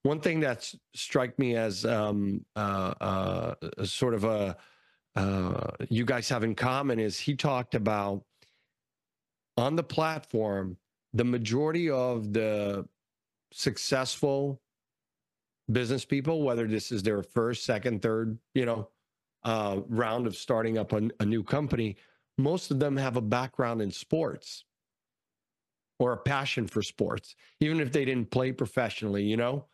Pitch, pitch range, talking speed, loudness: 115 Hz, 110-135 Hz, 145 wpm, -30 LUFS